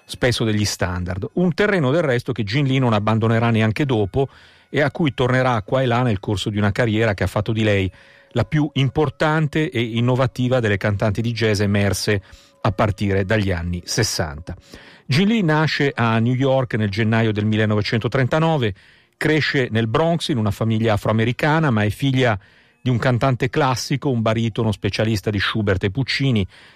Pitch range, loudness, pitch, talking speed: 105-135 Hz, -20 LUFS, 115 Hz, 175 wpm